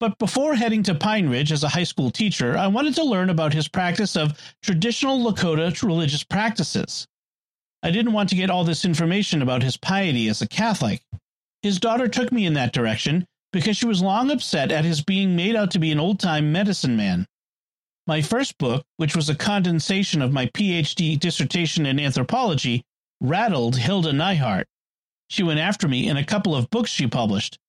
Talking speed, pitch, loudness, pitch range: 190 wpm, 175 Hz, -22 LUFS, 150-205 Hz